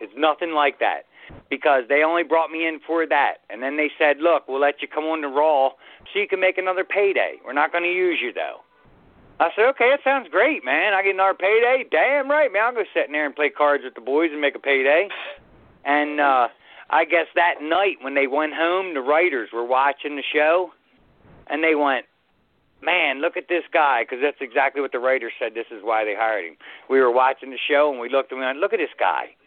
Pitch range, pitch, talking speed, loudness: 135-175 Hz, 150 Hz, 240 wpm, -21 LUFS